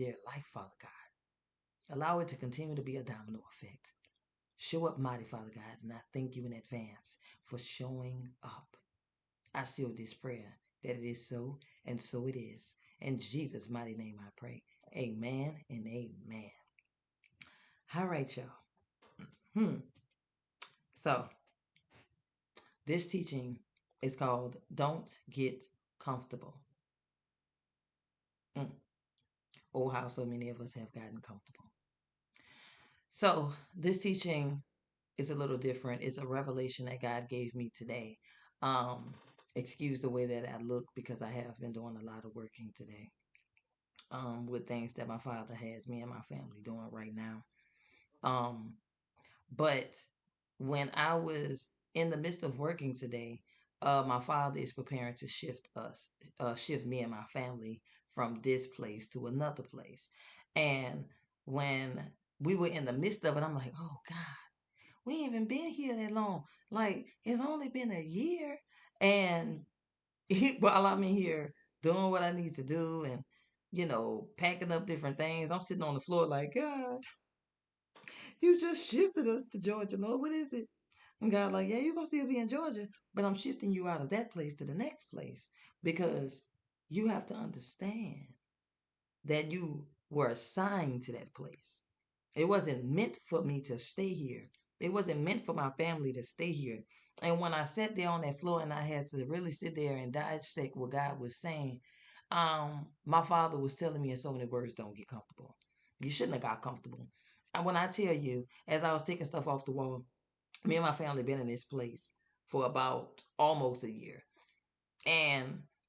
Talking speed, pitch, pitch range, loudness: 170 wpm, 140 Hz, 125-170 Hz, -37 LUFS